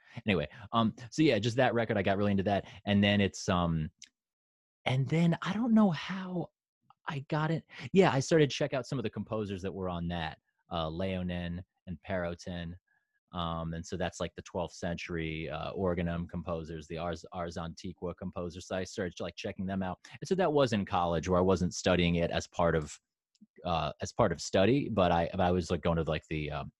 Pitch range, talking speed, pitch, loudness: 85-115 Hz, 215 wpm, 90 Hz, -32 LUFS